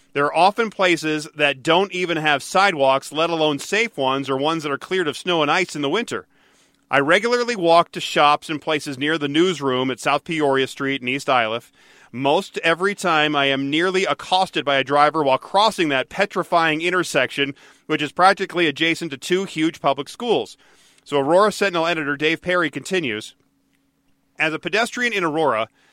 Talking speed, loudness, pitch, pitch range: 180 wpm, -19 LUFS, 160 Hz, 145-180 Hz